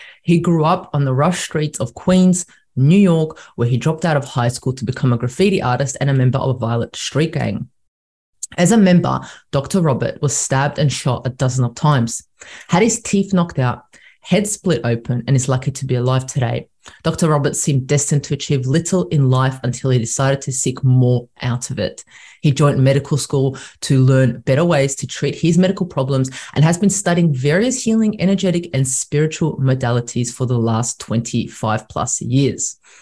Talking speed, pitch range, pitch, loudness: 195 wpm, 125-165 Hz, 135 Hz, -17 LUFS